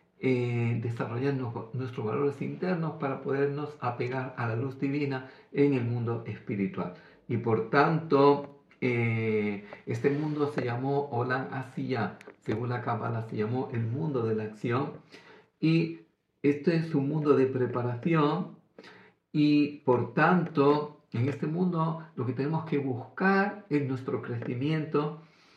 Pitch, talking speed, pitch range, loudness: 140 Hz, 135 wpm, 125-150 Hz, -29 LUFS